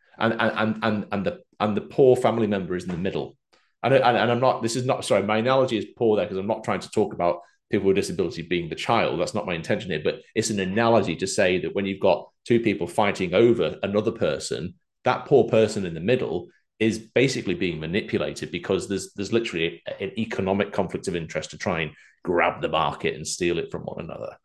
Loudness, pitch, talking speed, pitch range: -24 LUFS, 105 Hz, 230 wpm, 95-115 Hz